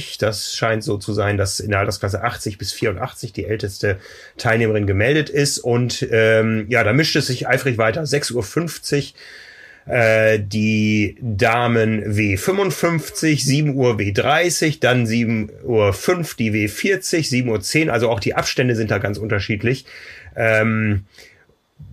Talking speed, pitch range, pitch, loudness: 140 wpm, 105-135 Hz, 115 Hz, -18 LUFS